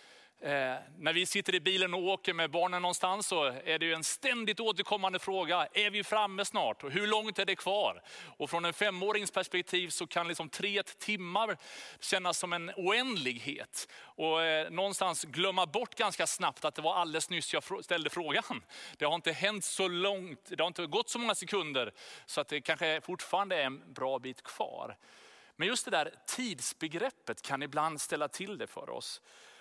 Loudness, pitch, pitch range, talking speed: -33 LUFS, 180 Hz, 160-200 Hz, 190 wpm